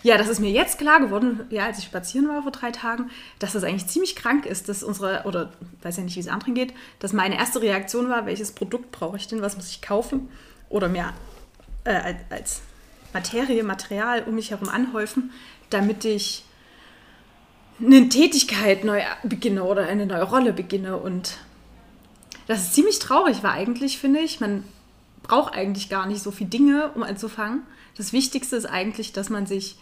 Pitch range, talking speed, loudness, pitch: 195-250 Hz, 185 wpm, -23 LUFS, 215 Hz